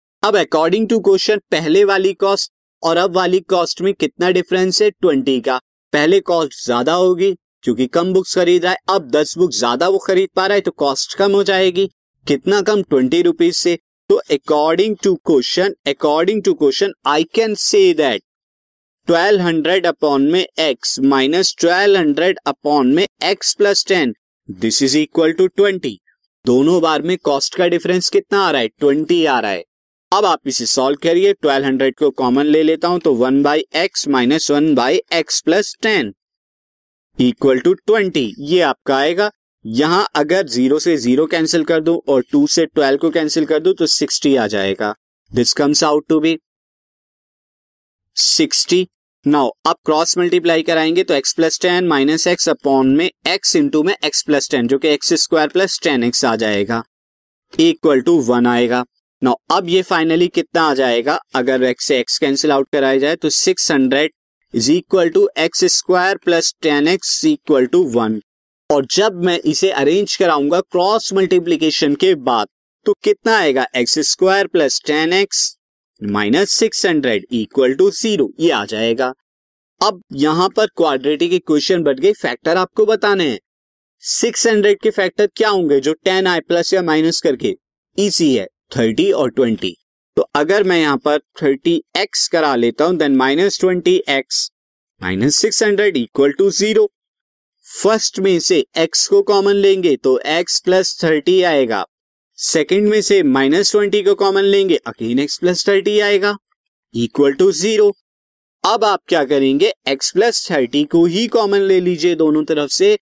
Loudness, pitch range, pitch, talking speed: -15 LUFS, 140-195 Hz, 170 Hz, 155 wpm